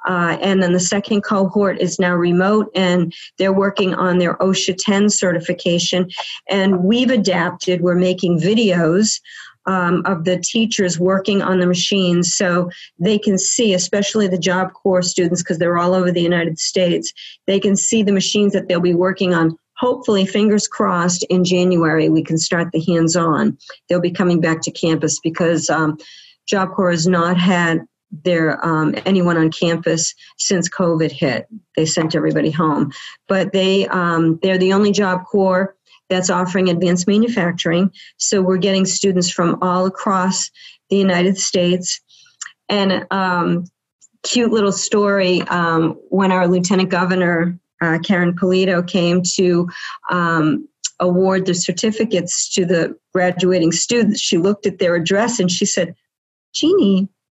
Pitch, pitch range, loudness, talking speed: 185 Hz, 175-195 Hz, -16 LUFS, 155 wpm